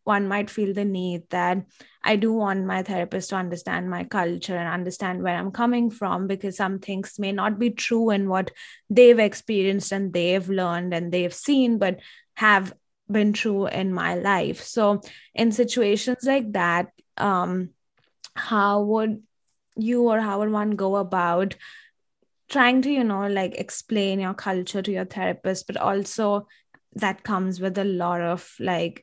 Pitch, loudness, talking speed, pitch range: 195 Hz, -24 LUFS, 165 wpm, 185-215 Hz